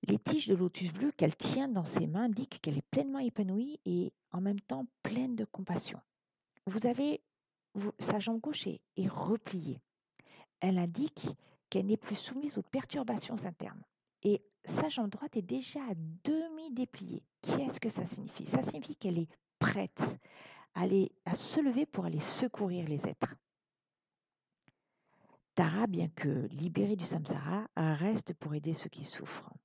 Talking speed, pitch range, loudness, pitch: 160 wpm, 175-250 Hz, -36 LUFS, 200 Hz